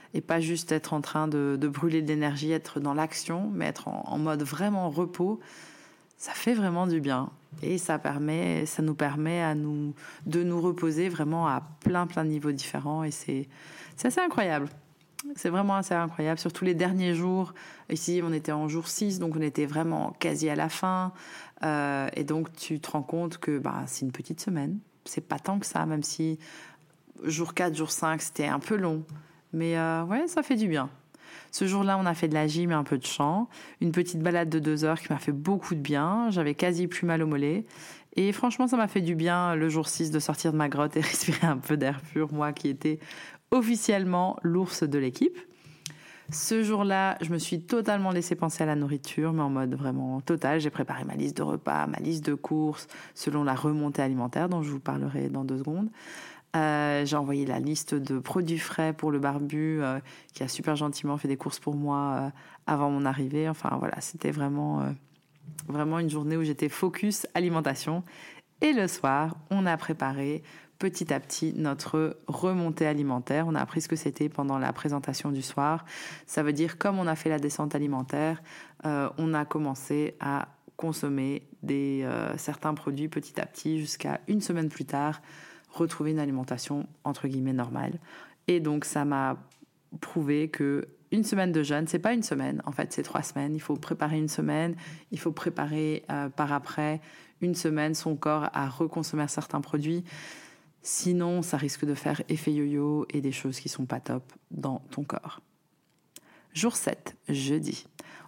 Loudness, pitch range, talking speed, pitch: -29 LUFS, 145-170 Hz, 195 wpm, 155 Hz